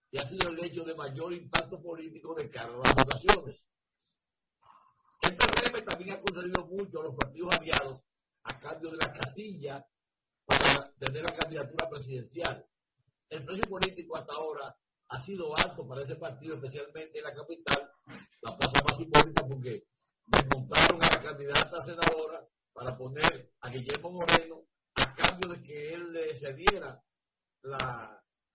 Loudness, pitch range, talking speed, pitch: -29 LUFS, 140-170 Hz, 145 wpm, 160 Hz